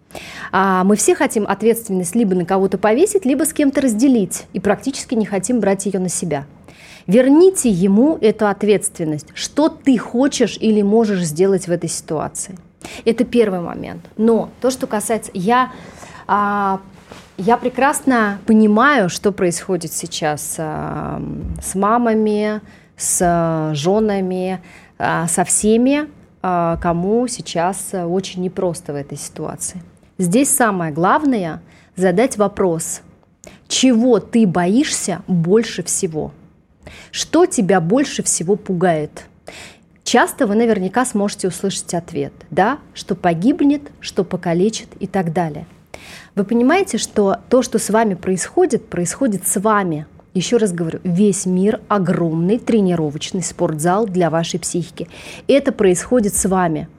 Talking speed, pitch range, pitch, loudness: 120 wpm, 180-230 Hz, 200 Hz, -17 LUFS